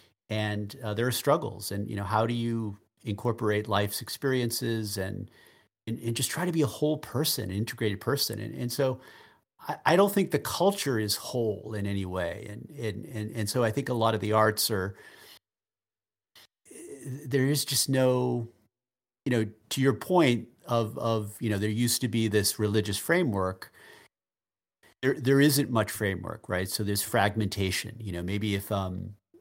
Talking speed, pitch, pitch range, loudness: 180 wpm, 110 Hz, 105-125 Hz, -28 LUFS